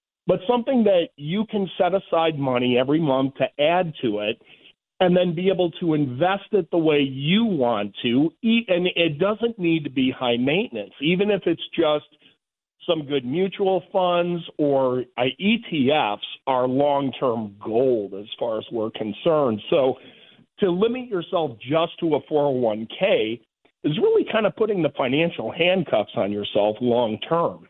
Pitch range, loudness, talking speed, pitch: 130-185 Hz, -22 LUFS, 160 wpm, 165 Hz